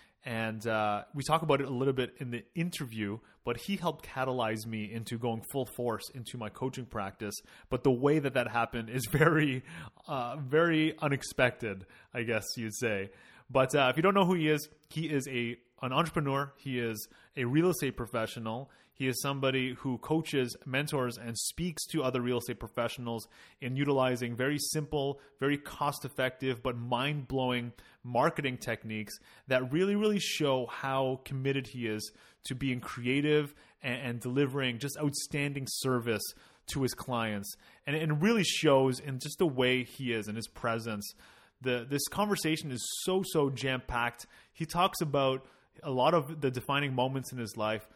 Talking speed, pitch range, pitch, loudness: 170 wpm, 120-145 Hz, 130 Hz, -32 LUFS